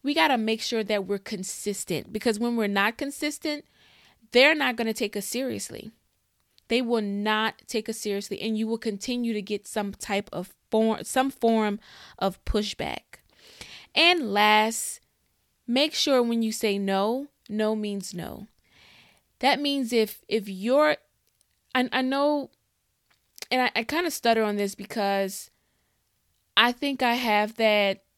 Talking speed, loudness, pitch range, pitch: 155 wpm, -25 LUFS, 205-250 Hz, 220 Hz